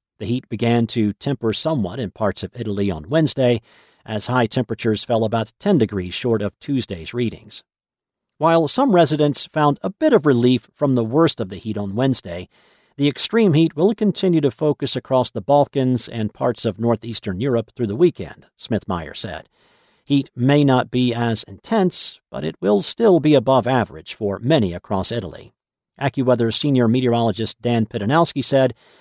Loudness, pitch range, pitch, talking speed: -19 LUFS, 110-145 Hz, 120 Hz, 170 wpm